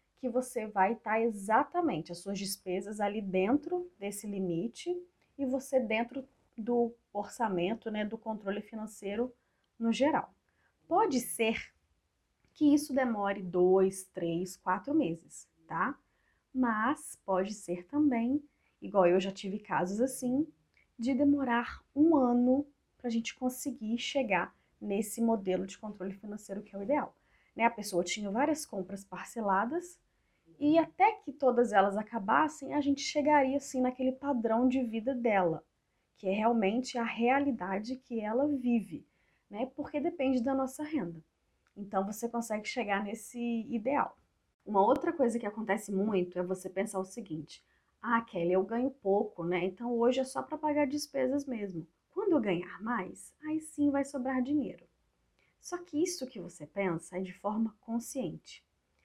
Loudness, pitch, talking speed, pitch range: -32 LUFS, 230 Hz, 150 wpm, 195-270 Hz